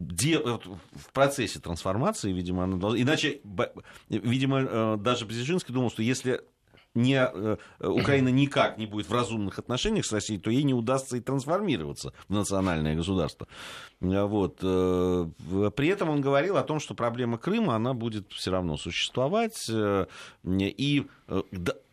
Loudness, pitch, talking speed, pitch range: -28 LUFS, 110 Hz, 130 wpm, 95-130 Hz